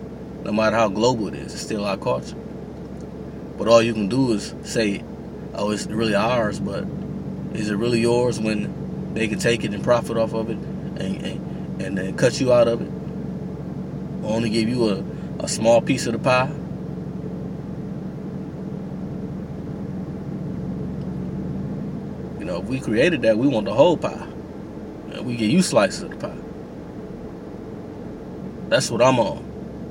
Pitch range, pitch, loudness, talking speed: 115-180 Hz, 155 Hz, -23 LUFS, 155 wpm